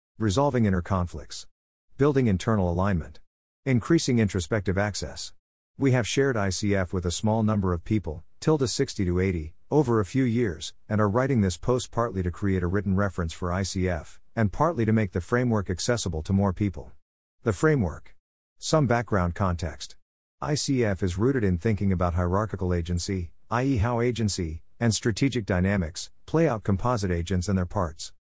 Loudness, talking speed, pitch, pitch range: -26 LUFS, 160 wpm, 100 Hz, 90-115 Hz